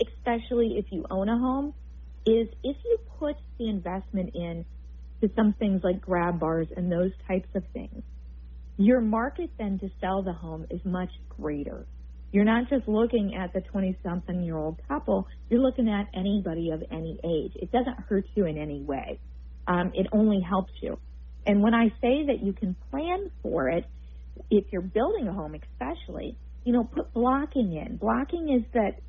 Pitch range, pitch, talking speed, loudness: 165-230 Hz, 195 Hz, 180 wpm, -28 LUFS